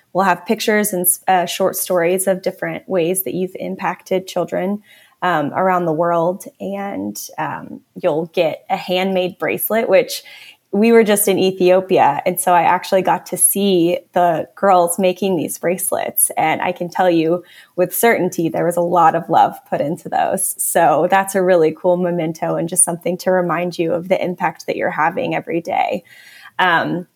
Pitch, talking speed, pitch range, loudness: 180 Hz, 175 wpm, 175-190 Hz, -17 LUFS